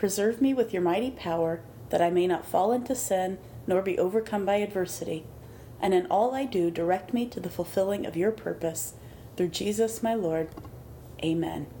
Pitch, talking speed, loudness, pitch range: 185 Hz, 185 wpm, -28 LUFS, 165-220 Hz